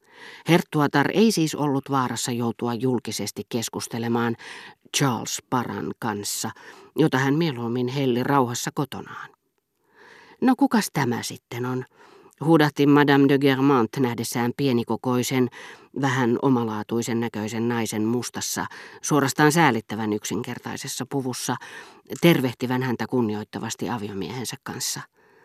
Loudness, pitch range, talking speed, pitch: -23 LUFS, 115-140 Hz, 100 wpm, 125 Hz